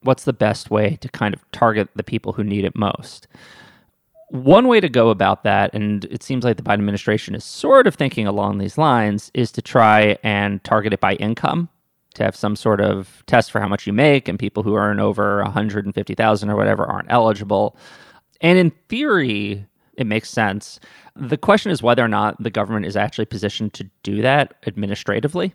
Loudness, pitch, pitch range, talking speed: -18 LUFS, 105 Hz, 105-125 Hz, 195 wpm